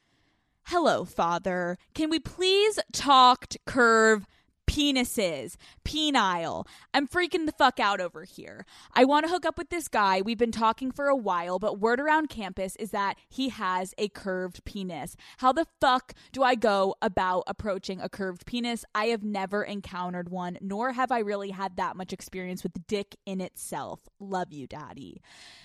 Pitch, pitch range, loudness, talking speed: 210 Hz, 190-260 Hz, -27 LUFS, 175 wpm